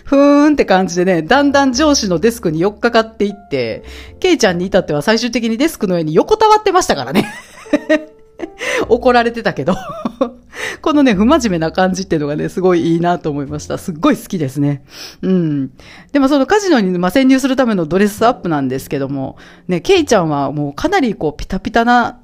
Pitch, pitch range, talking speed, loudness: 220 Hz, 175-280 Hz, 415 characters per minute, -14 LUFS